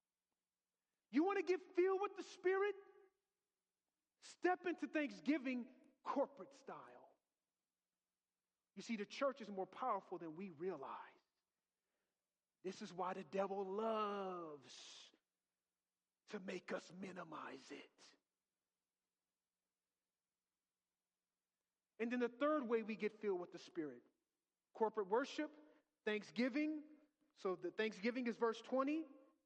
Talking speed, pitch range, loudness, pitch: 110 wpm, 200-305 Hz, -44 LUFS, 240 Hz